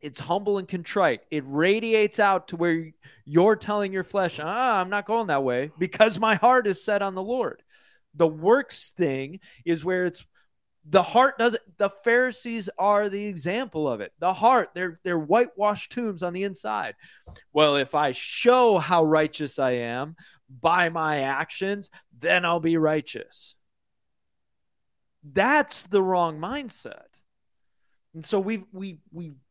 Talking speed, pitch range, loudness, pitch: 155 wpm, 160-210 Hz, -24 LUFS, 185 Hz